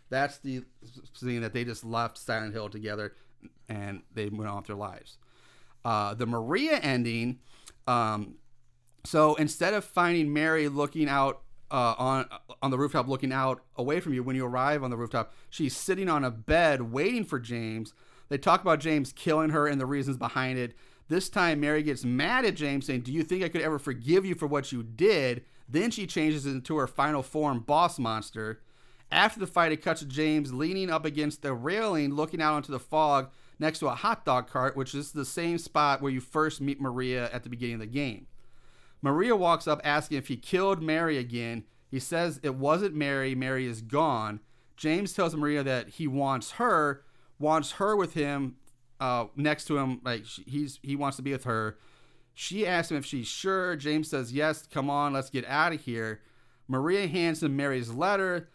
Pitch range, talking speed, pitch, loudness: 125-155 Hz, 200 wpm, 140 Hz, -29 LUFS